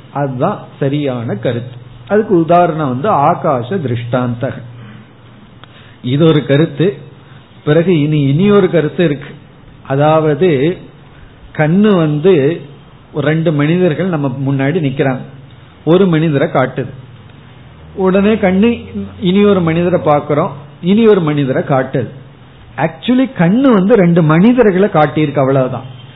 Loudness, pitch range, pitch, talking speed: -12 LUFS, 130-175 Hz, 145 Hz, 105 wpm